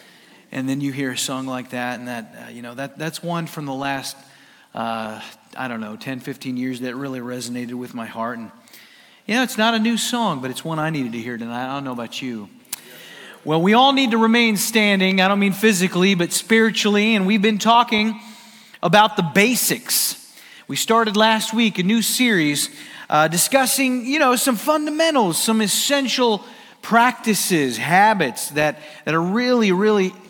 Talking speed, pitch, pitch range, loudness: 190 wpm, 185 Hz, 135-225 Hz, -19 LUFS